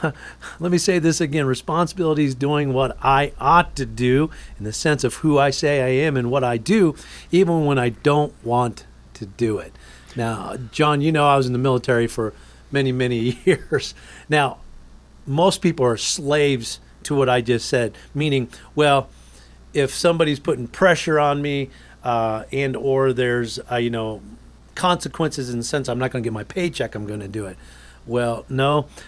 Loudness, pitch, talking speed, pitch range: -20 LUFS, 130 Hz, 185 wpm, 115-150 Hz